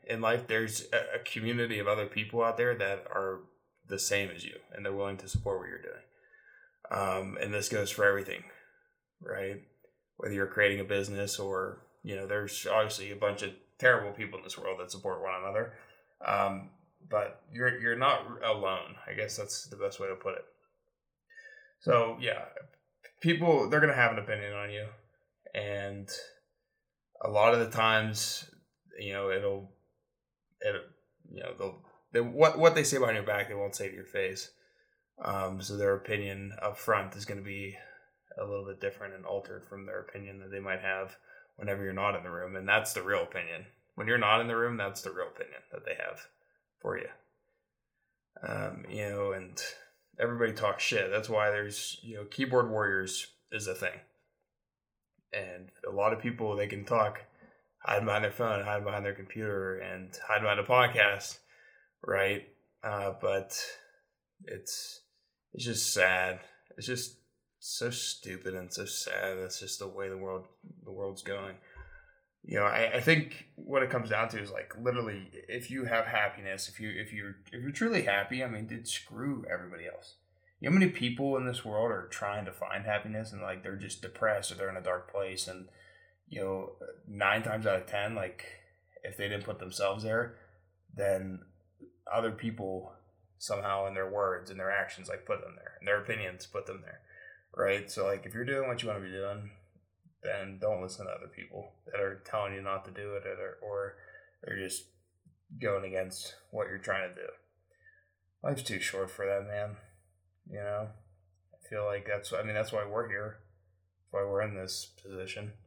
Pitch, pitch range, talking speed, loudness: 105 Hz, 95-120 Hz, 190 wpm, -33 LUFS